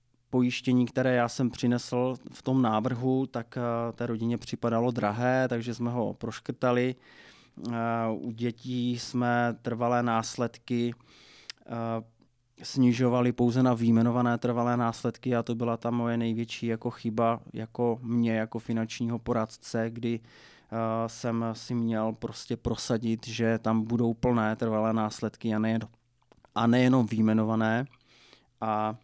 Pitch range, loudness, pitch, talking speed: 115-120 Hz, -29 LUFS, 120 Hz, 130 wpm